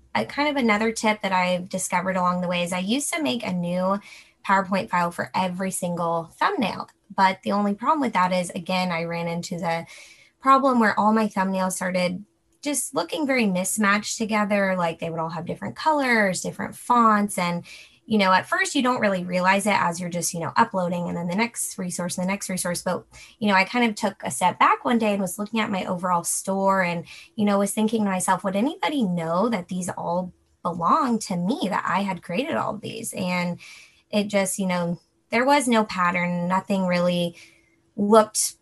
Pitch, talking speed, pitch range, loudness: 190 Hz, 210 wpm, 180-215 Hz, -23 LUFS